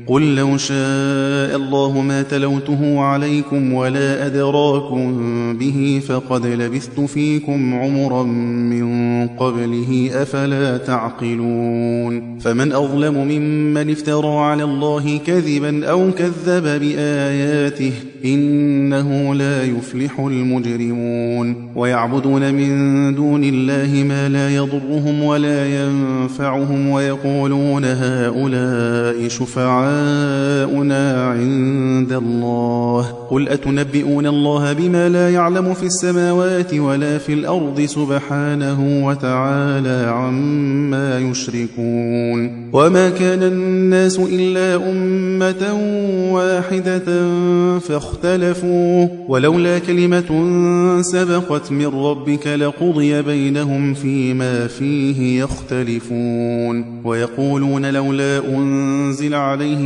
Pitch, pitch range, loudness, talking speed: 140 Hz, 130-150 Hz, -17 LUFS, 80 wpm